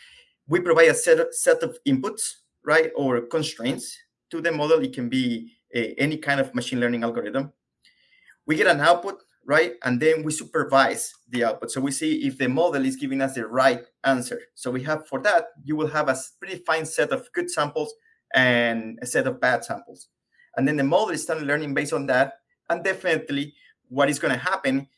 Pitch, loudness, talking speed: 155 Hz, -23 LUFS, 205 wpm